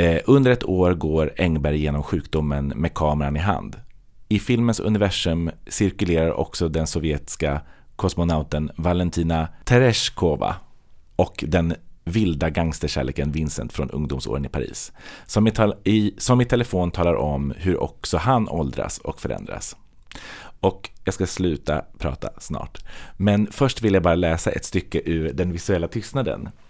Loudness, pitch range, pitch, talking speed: -22 LUFS, 80-100 Hz, 85 Hz, 140 wpm